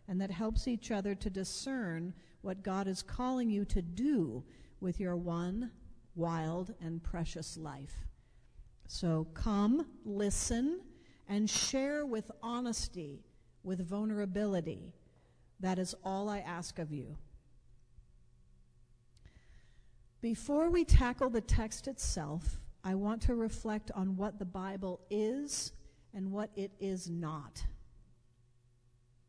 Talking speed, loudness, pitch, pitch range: 115 wpm, -37 LUFS, 190 Hz, 165-220 Hz